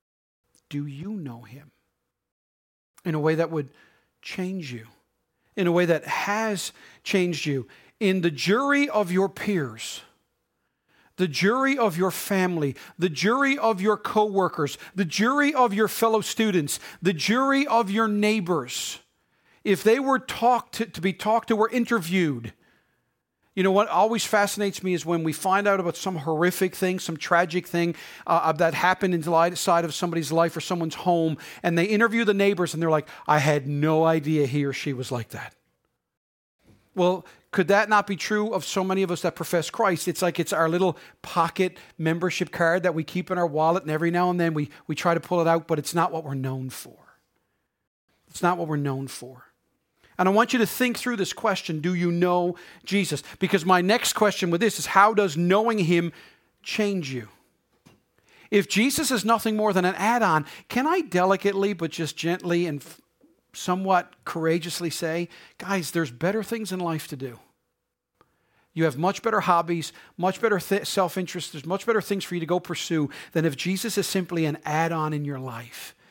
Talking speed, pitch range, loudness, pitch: 190 wpm, 160-200 Hz, -24 LUFS, 180 Hz